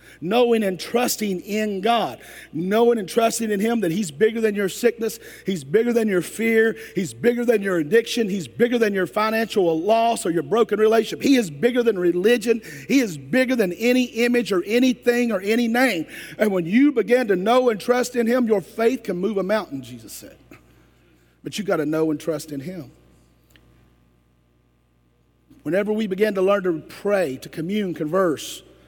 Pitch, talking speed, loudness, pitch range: 210 Hz, 185 wpm, -21 LUFS, 165-230 Hz